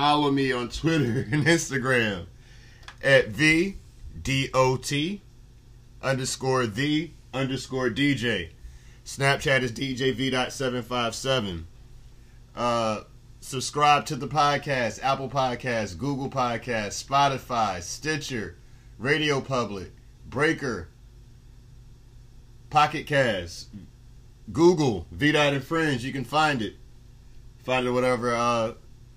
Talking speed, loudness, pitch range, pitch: 105 wpm, -25 LUFS, 120-140 Hz, 125 Hz